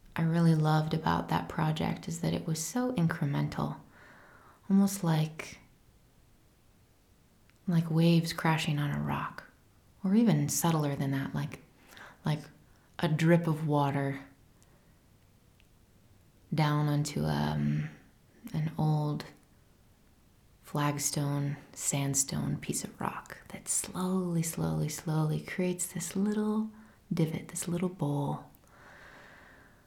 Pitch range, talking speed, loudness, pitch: 140-170 Hz, 105 wpm, -31 LUFS, 155 Hz